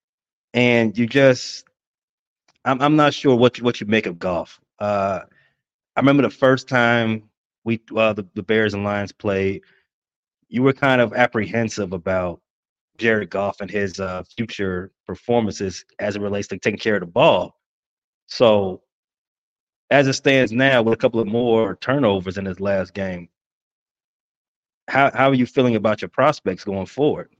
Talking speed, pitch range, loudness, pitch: 165 wpm, 100-125 Hz, -20 LUFS, 110 Hz